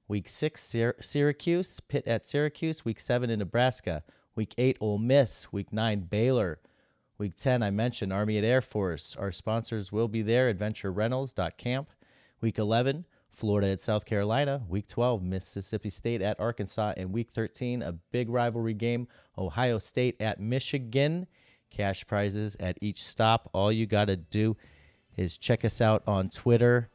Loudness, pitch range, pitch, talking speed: -30 LUFS, 100-125 Hz, 110 Hz, 160 wpm